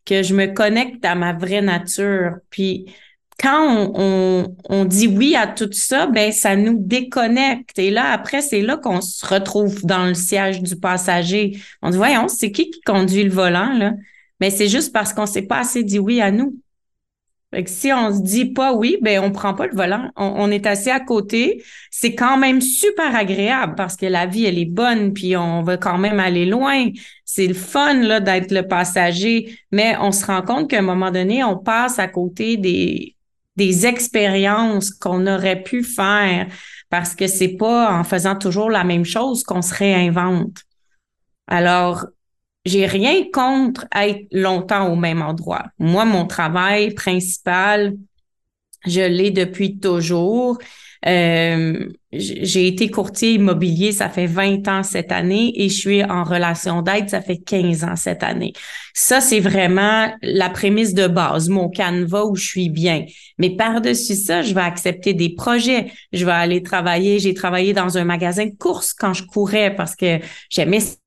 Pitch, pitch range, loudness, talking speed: 195 Hz, 180-220 Hz, -17 LUFS, 180 wpm